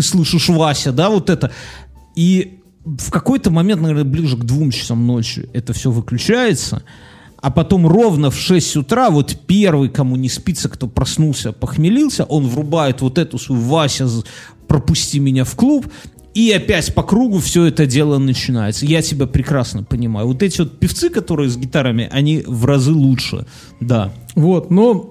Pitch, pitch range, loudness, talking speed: 145 Hz, 125-170 Hz, -15 LUFS, 165 wpm